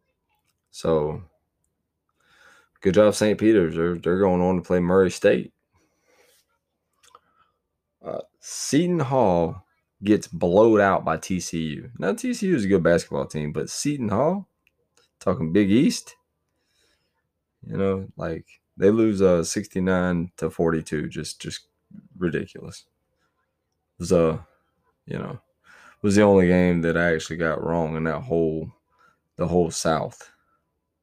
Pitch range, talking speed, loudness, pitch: 80-100 Hz, 135 wpm, -22 LUFS, 90 Hz